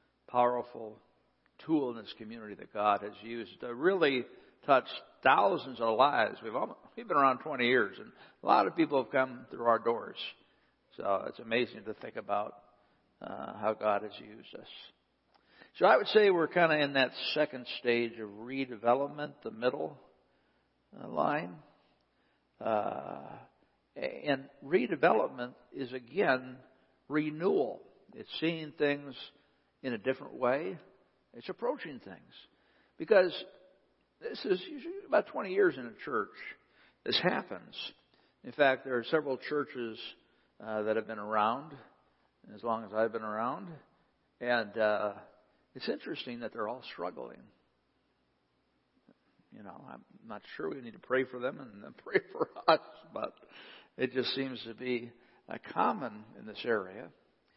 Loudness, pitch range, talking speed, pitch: -32 LUFS, 115-140 Hz, 145 wpm, 125 Hz